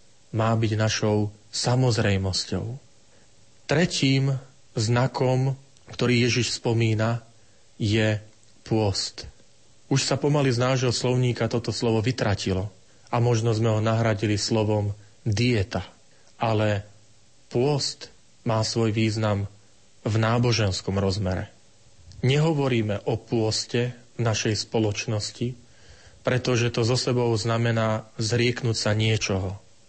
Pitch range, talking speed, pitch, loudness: 105-120 Hz, 100 wpm, 115 Hz, -25 LUFS